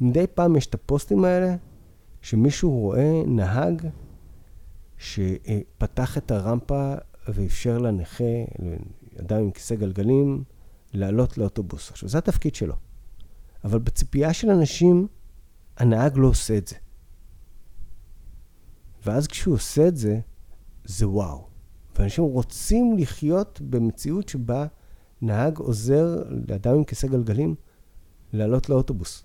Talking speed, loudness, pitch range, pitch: 110 wpm, -24 LUFS, 95-140 Hz, 115 Hz